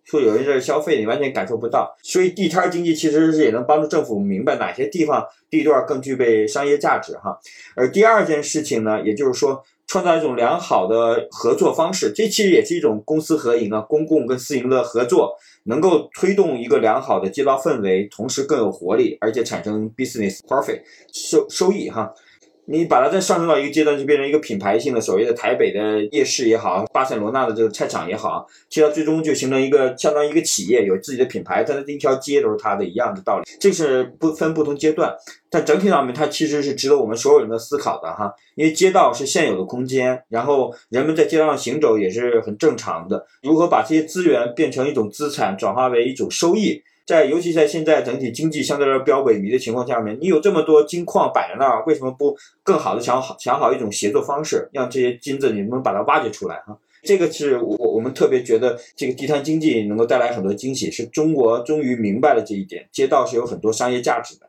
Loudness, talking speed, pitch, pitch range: -19 LUFS, 365 characters per minute, 150 Hz, 125-175 Hz